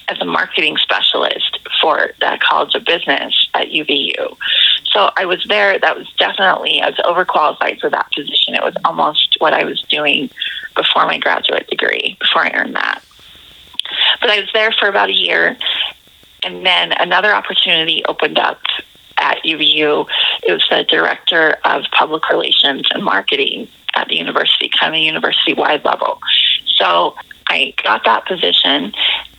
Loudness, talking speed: -13 LUFS, 155 wpm